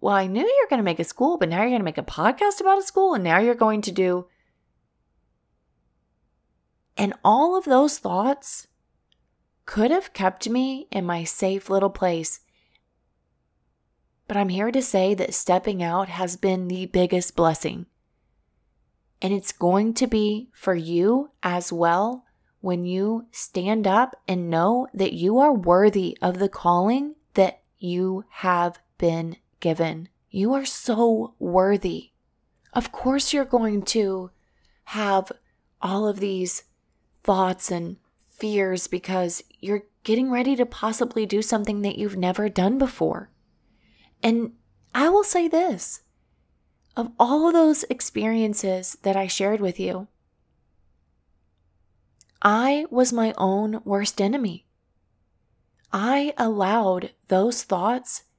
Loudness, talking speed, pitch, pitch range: -23 LUFS, 135 wpm, 195 Hz, 175-235 Hz